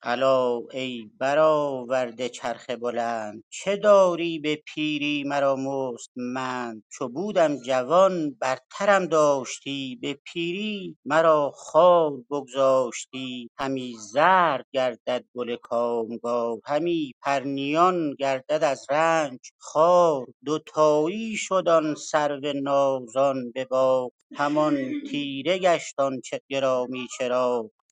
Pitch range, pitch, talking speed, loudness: 125-155 Hz, 140 Hz, 100 wpm, -24 LUFS